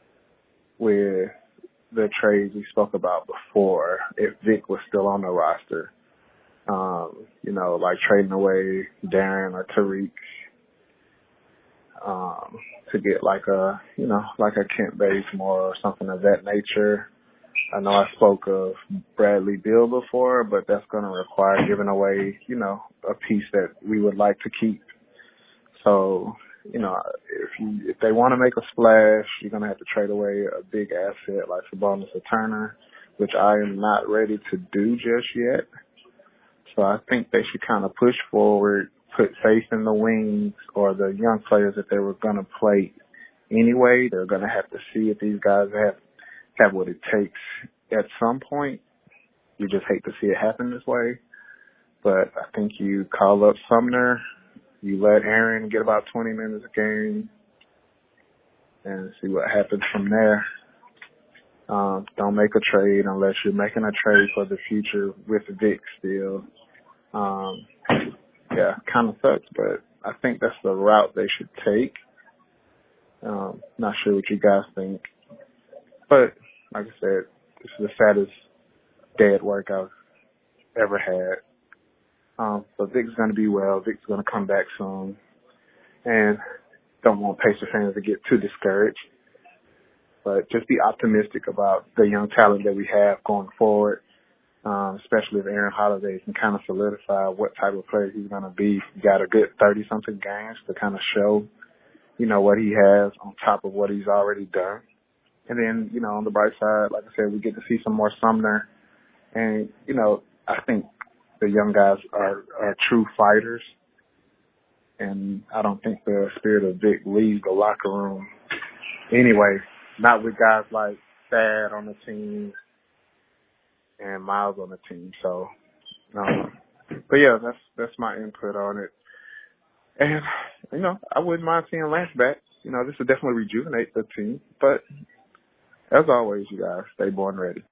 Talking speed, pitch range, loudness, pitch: 170 wpm, 100-115 Hz, -22 LUFS, 105 Hz